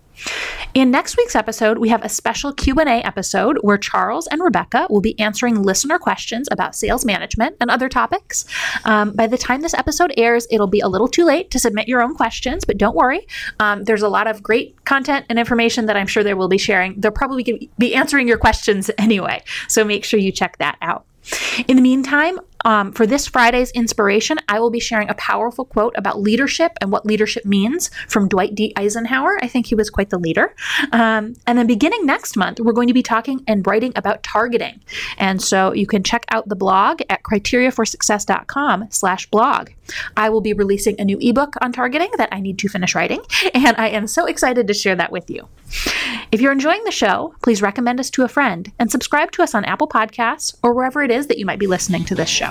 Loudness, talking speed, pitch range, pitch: -17 LUFS, 215 wpm, 210-260 Hz, 230 Hz